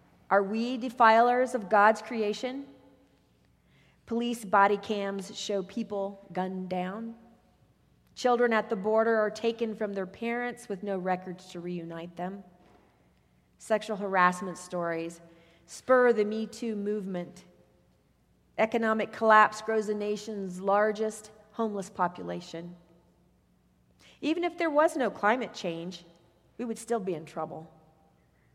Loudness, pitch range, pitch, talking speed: -29 LUFS, 180-225 Hz, 210 Hz, 120 wpm